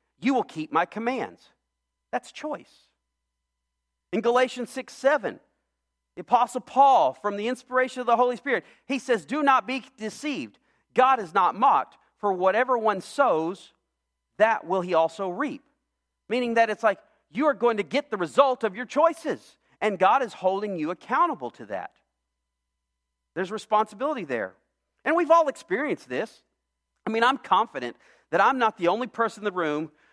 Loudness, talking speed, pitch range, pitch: -25 LUFS, 165 wpm, 165-260 Hz, 220 Hz